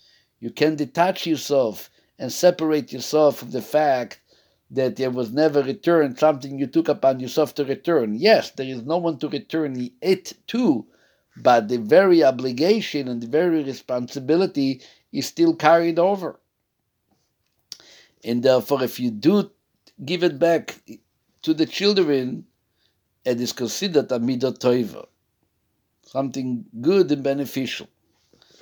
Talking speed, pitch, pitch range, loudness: 130 wpm, 145 Hz, 125-170 Hz, -21 LUFS